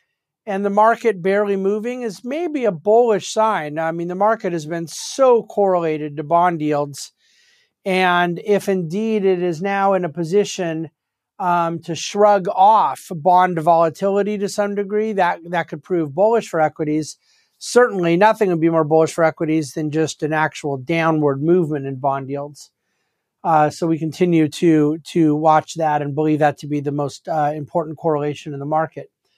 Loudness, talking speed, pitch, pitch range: -18 LUFS, 170 wpm, 170 Hz, 155-200 Hz